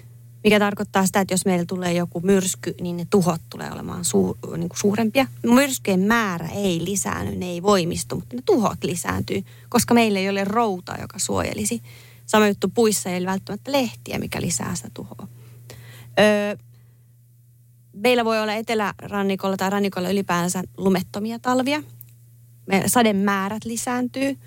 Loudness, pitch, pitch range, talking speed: -22 LUFS, 195 Hz, 155-210 Hz, 150 wpm